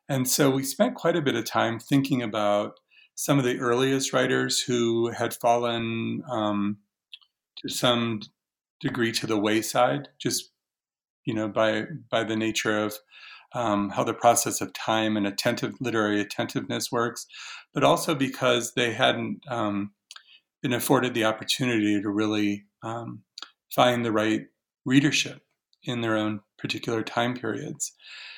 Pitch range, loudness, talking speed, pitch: 110-130 Hz, -26 LUFS, 145 wpm, 115 Hz